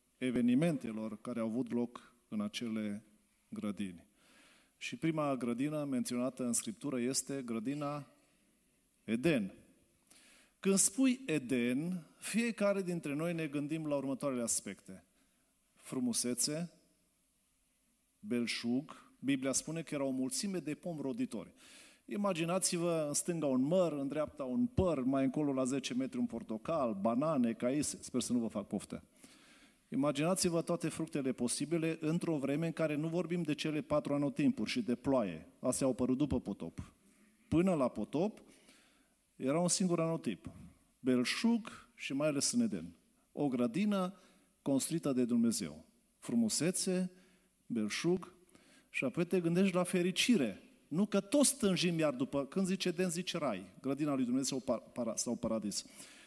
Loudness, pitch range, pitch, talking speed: -35 LUFS, 125-180 Hz, 150 Hz, 135 wpm